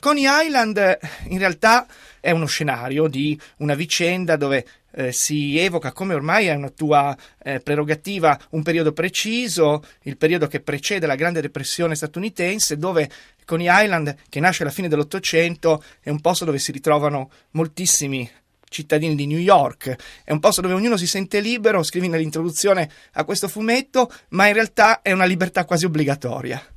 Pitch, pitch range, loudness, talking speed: 165 Hz, 150-190 Hz, -19 LUFS, 160 wpm